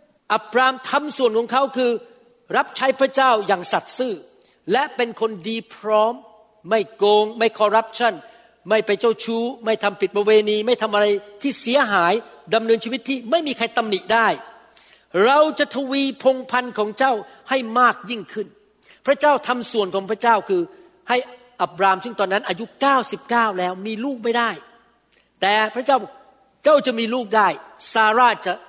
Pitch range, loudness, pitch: 215-265 Hz, -20 LUFS, 230 Hz